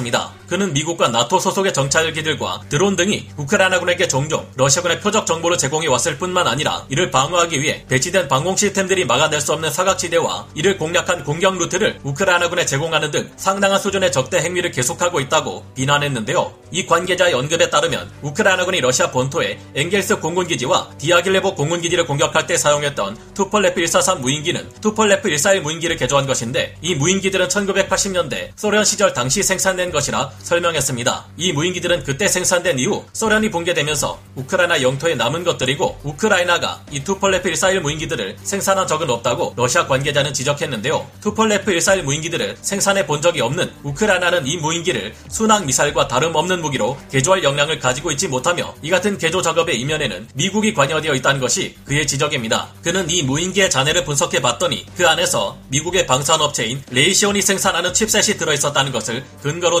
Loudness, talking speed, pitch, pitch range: -17 LUFS, 440 characters per minute, 170 Hz, 145-190 Hz